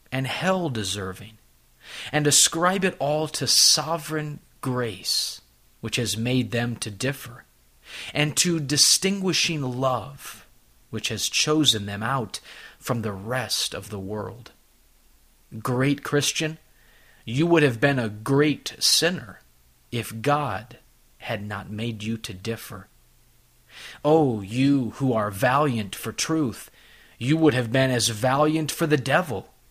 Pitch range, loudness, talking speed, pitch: 110-150 Hz, -23 LUFS, 130 wpm, 125 Hz